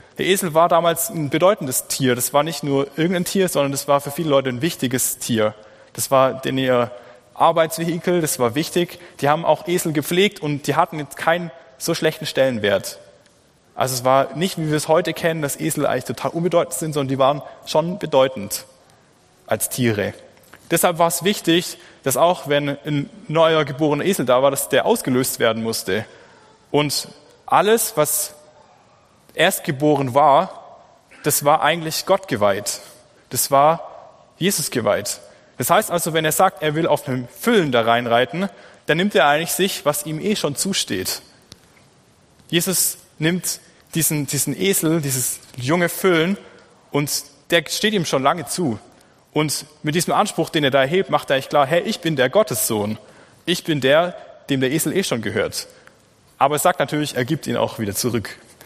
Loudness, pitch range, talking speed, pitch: -19 LUFS, 135-170 Hz, 175 wpm, 155 Hz